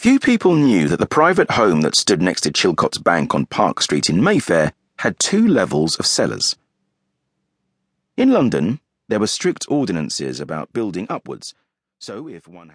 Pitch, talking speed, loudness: 205 Hz, 165 wpm, -17 LUFS